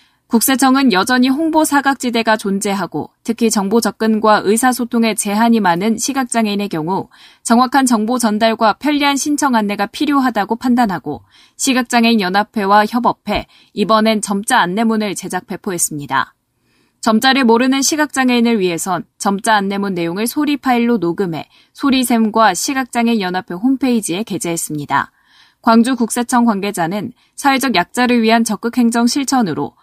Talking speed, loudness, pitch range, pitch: 355 characters per minute, -15 LUFS, 200-255 Hz, 225 Hz